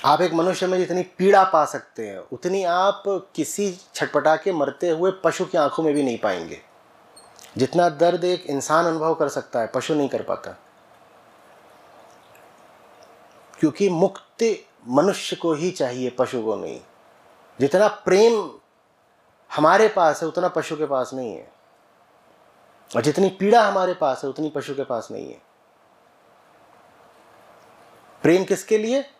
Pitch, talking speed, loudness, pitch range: 175 Hz, 145 wpm, -21 LUFS, 150-190 Hz